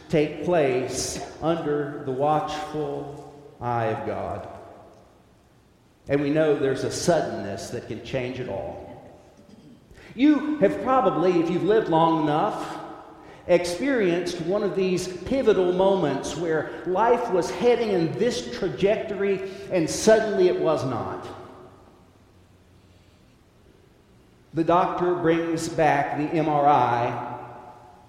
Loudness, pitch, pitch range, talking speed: -24 LUFS, 160 Hz, 135-185 Hz, 110 wpm